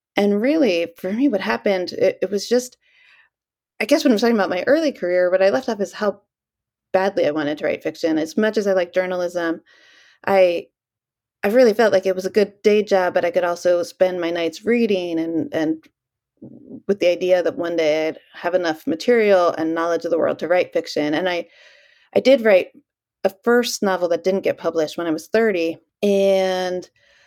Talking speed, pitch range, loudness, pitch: 205 wpm, 170-220 Hz, -19 LUFS, 185 Hz